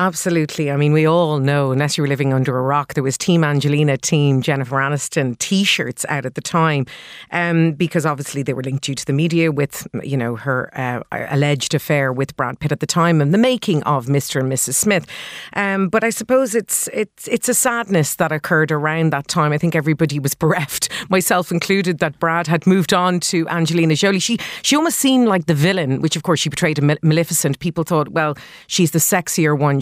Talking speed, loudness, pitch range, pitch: 215 wpm, -17 LUFS, 145-180 Hz, 160 Hz